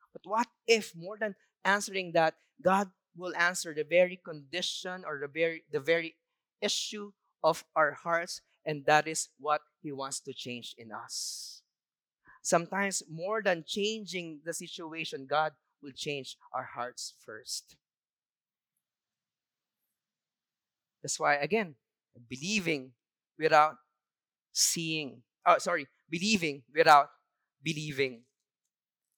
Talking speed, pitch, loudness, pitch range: 115 wpm, 165 Hz, -31 LUFS, 150-190 Hz